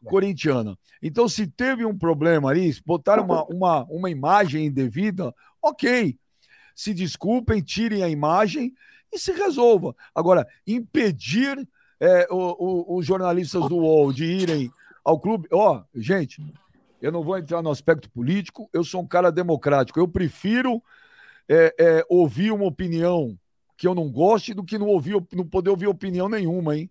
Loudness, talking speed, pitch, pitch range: -22 LUFS, 160 wpm, 180 Hz, 160-215 Hz